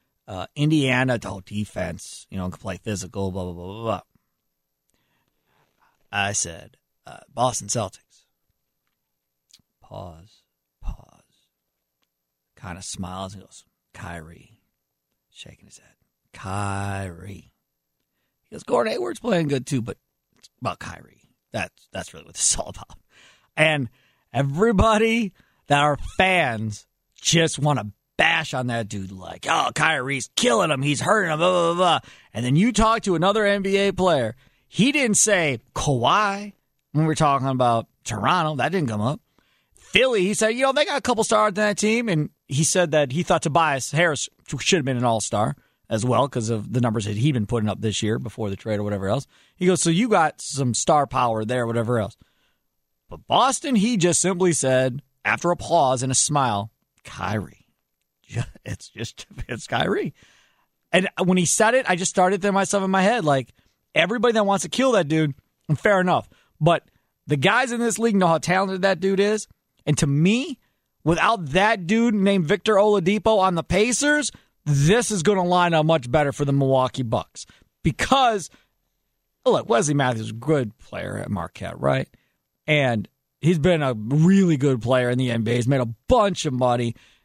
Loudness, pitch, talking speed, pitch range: -21 LUFS, 145 Hz, 175 wpm, 110-190 Hz